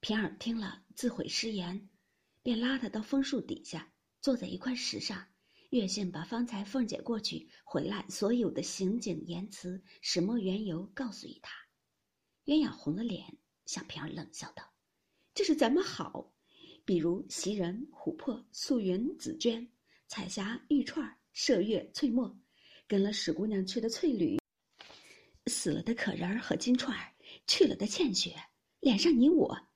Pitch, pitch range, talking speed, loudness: 230 Hz, 195-275 Hz, 225 characters per minute, -33 LUFS